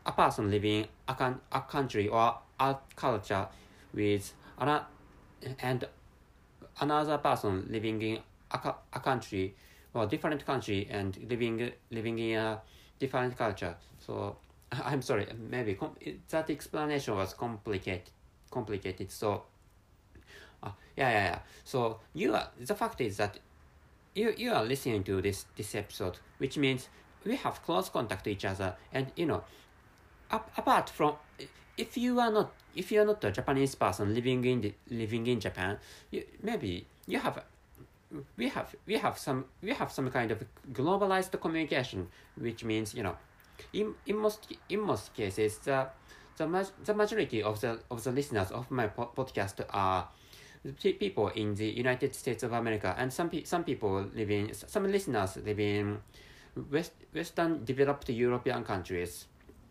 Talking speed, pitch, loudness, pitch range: 160 wpm, 115 Hz, -33 LUFS, 105-135 Hz